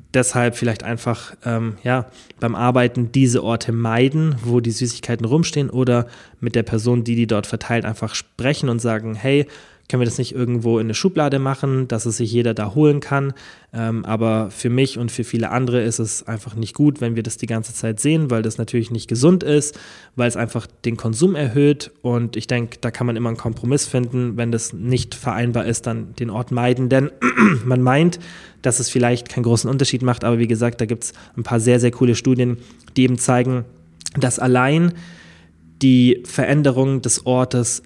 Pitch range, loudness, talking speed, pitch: 115-130 Hz, -19 LUFS, 195 wpm, 120 Hz